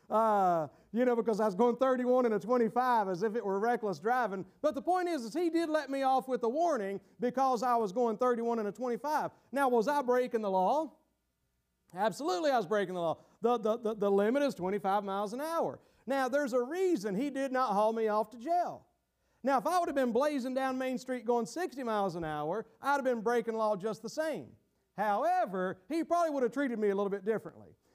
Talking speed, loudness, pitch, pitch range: 230 wpm, -32 LUFS, 240 Hz, 210-275 Hz